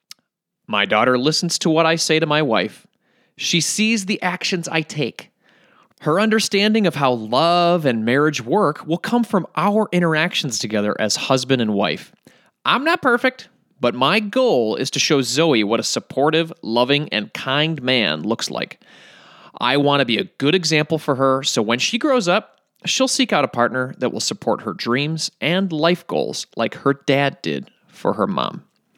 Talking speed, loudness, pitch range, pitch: 180 wpm, -19 LUFS, 135-185 Hz, 155 Hz